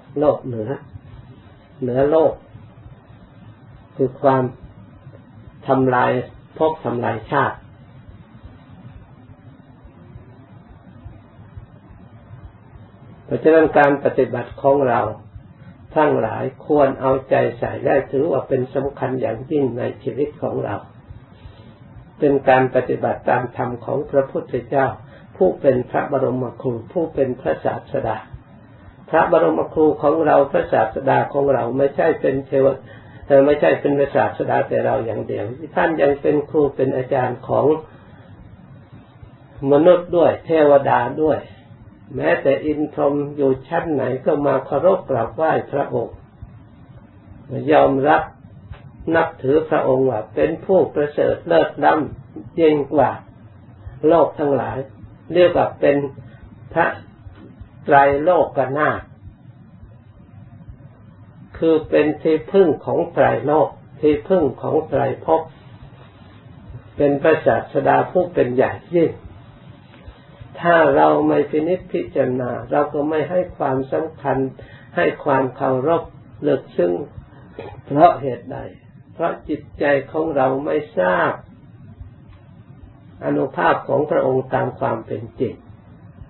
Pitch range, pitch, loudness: 115-145 Hz, 135 Hz, -18 LUFS